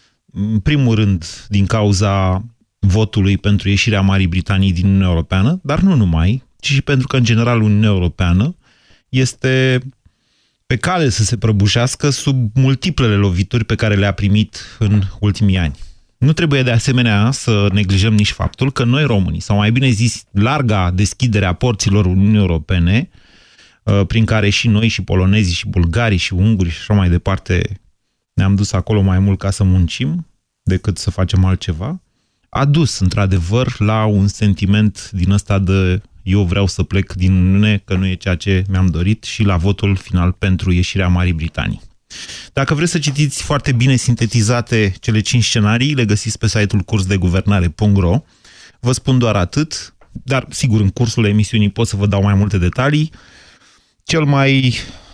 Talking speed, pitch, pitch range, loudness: 165 wpm, 105 Hz, 95-120 Hz, -15 LUFS